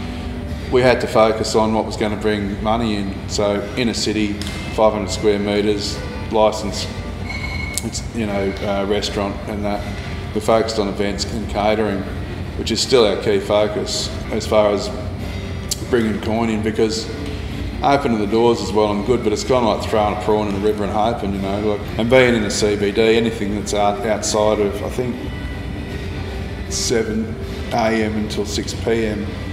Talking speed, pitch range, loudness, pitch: 170 wpm, 100-110 Hz, -19 LUFS, 105 Hz